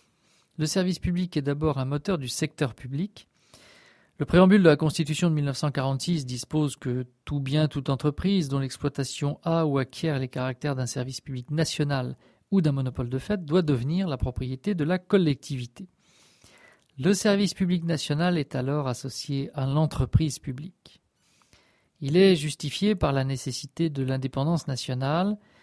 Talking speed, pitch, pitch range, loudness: 150 wpm, 145 Hz, 135-165 Hz, -26 LUFS